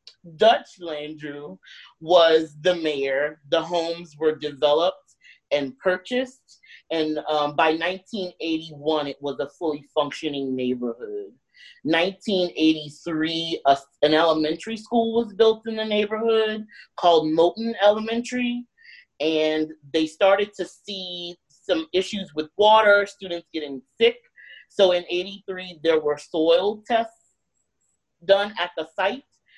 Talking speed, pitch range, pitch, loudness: 115 wpm, 155-205 Hz, 170 Hz, -23 LUFS